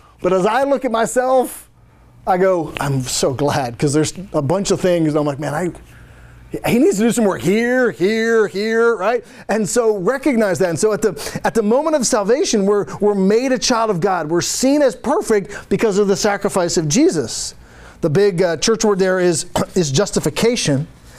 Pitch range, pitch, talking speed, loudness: 175-225 Hz, 205 Hz, 200 wpm, -17 LUFS